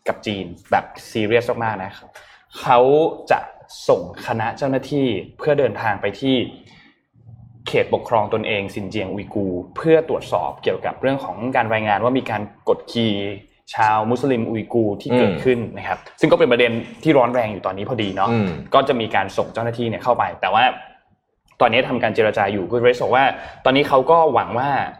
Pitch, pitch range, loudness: 115 Hz, 100-130 Hz, -19 LUFS